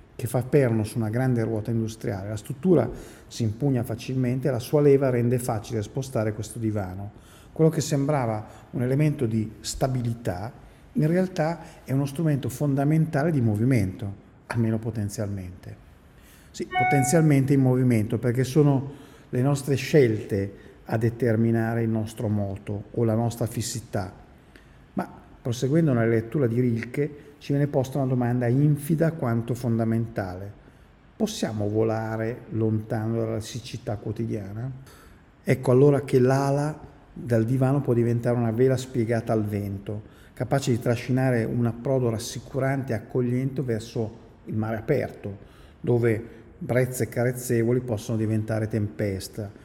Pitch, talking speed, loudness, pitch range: 120 Hz, 130 wpm, -25 LUFS, 110-135 Hz